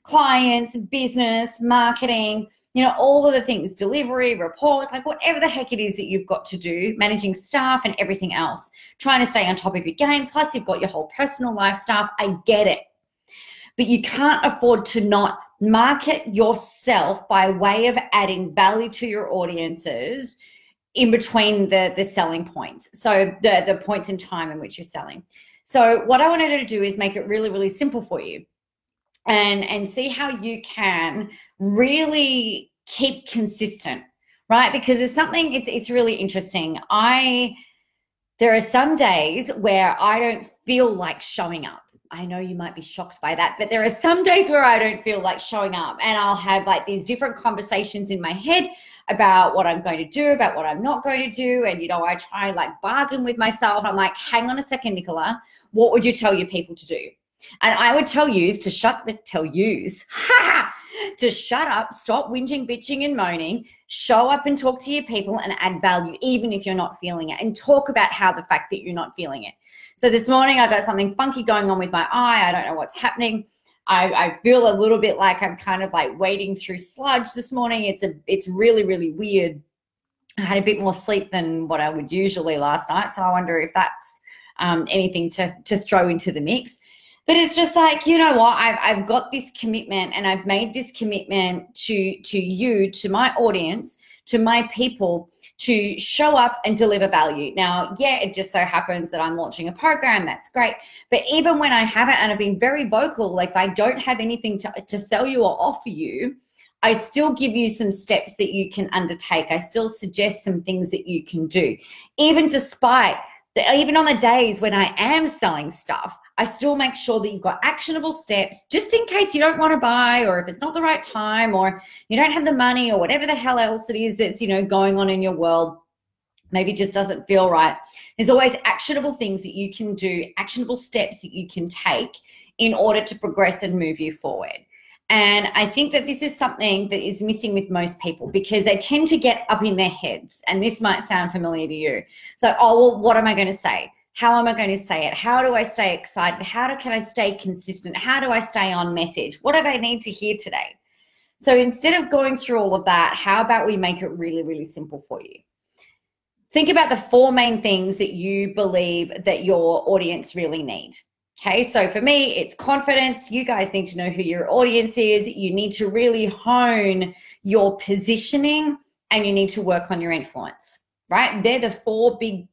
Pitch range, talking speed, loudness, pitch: 190-250 Hz, 210 wpm, -20 LUFS, 215 Hz